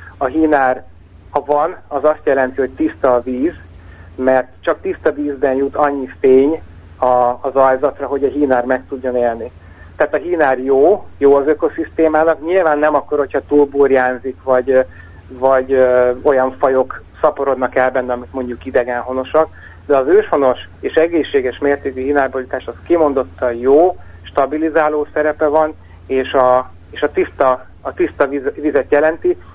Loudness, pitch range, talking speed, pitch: -15 LUFS, 125-145 Hz, 150 wpm, 135 Hz